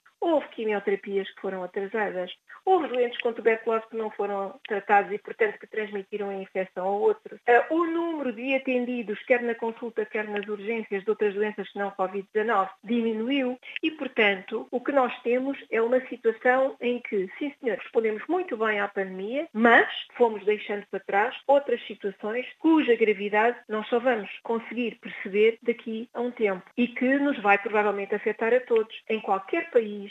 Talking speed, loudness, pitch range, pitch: 170 wpm, -26 LUFS, 205-250 Hz, 225 Hz